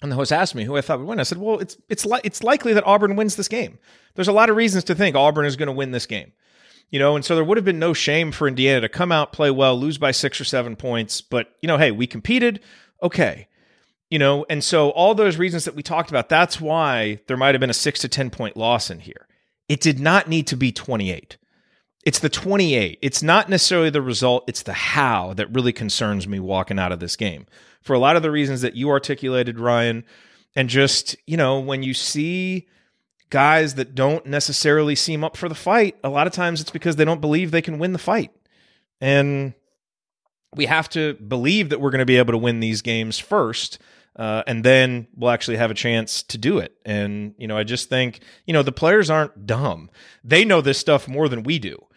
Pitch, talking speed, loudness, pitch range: 145 Hz, 240 wpm, -19 LUFS, 125-165 Hz